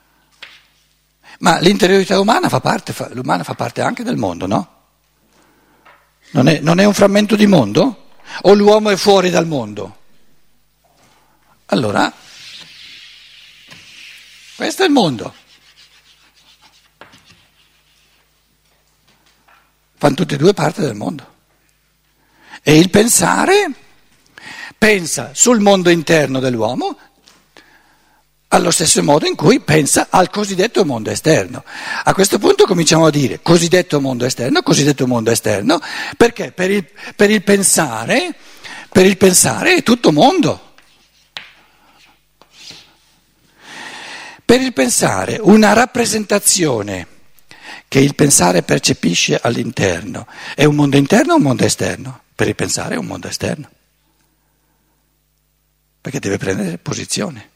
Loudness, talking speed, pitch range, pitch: -13 LUFS, 115 wpm, 145-215 Hz, 185 Hz